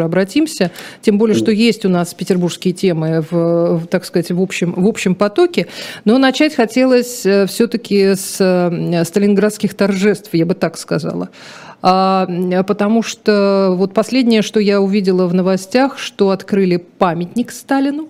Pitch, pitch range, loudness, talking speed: 195 Hz, 180-220 Hz, -15 LUFS, 135 wpm